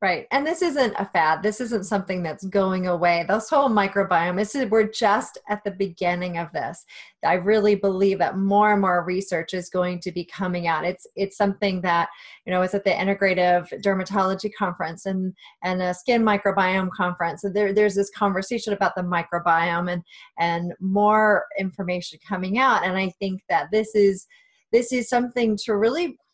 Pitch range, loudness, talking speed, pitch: 180-210 Hz, -23 LUFS, 185 wpm, 195 Hz